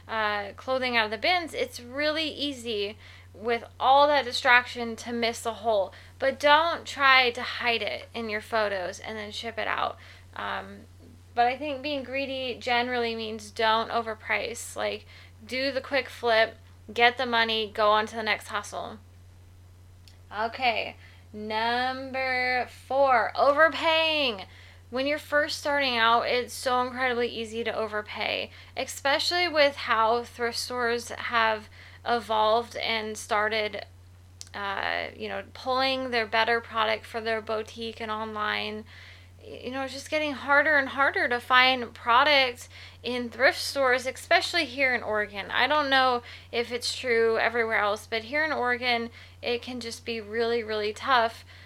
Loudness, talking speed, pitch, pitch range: -26 LUFS, 150 wpm, 235 Hz, 215-260 Hz